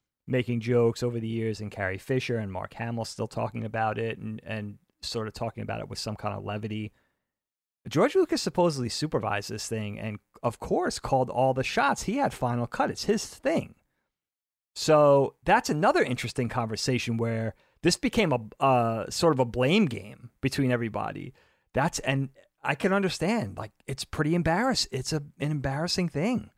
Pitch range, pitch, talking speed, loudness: 110-145 Hz, 120 Hz, 175 wpm, -28 LUFS